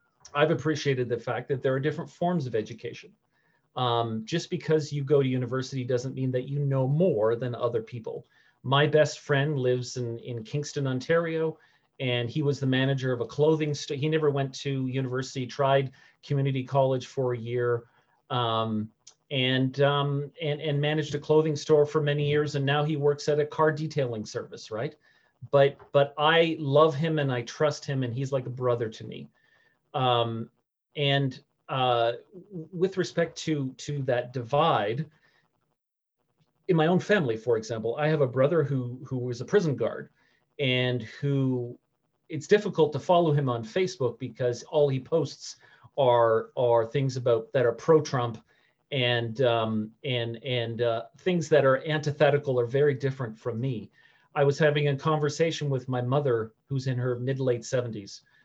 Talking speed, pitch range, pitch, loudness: 170 wpm, 125-150 Hz, 135 Hz, -27 LUFS